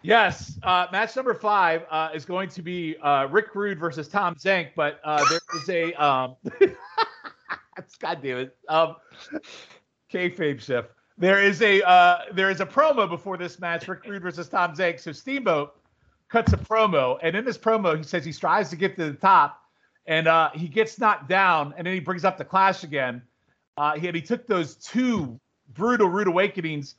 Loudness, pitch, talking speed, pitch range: -23 LUFS, 180 Hz, 190 wpm, 160-205 Hz